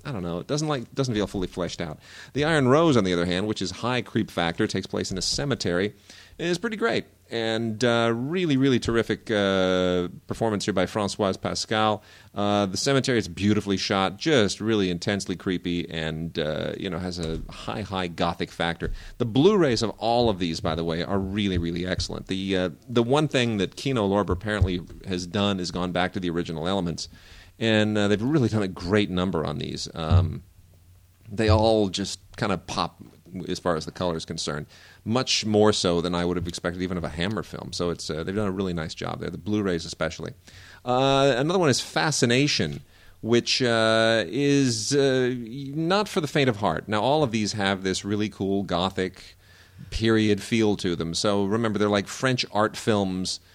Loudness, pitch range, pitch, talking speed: -25 LUFS, 90-115 Hz, 100 Hz, 200 wpm